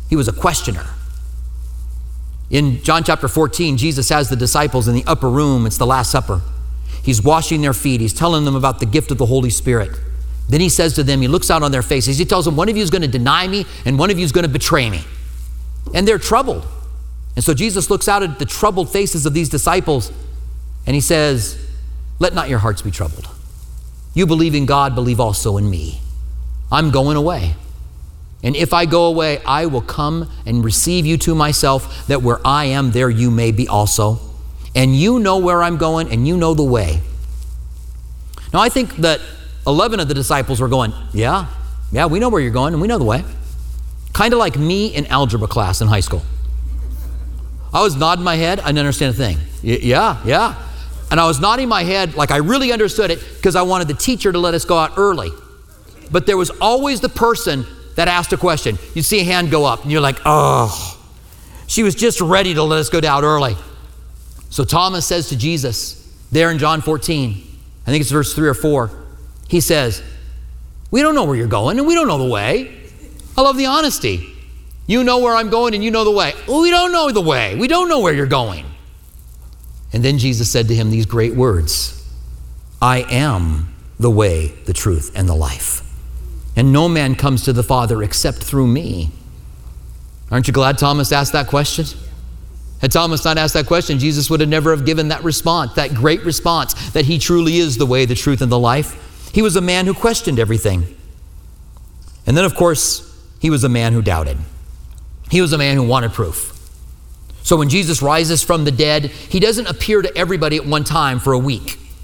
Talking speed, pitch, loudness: 210 wpm, 130 Hz, -15 LUFS